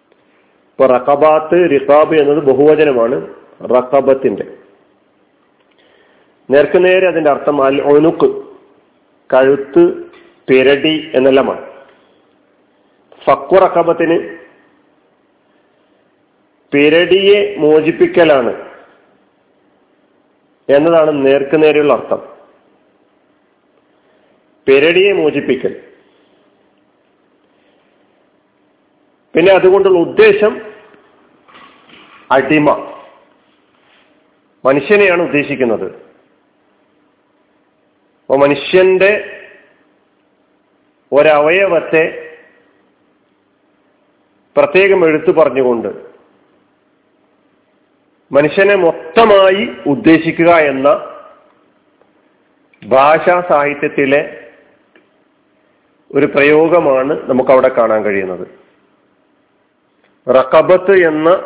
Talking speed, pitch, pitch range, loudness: 45 wpm, 160 Hz, 140-200 Hz, -11 LUFS